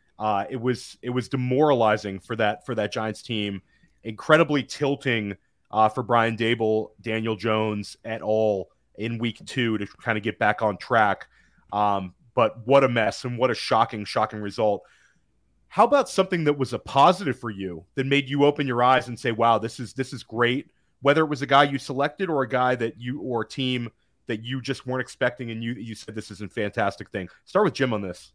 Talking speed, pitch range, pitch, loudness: 210 wpm, 110-135 Hz, 120 Hz, -24 LUFS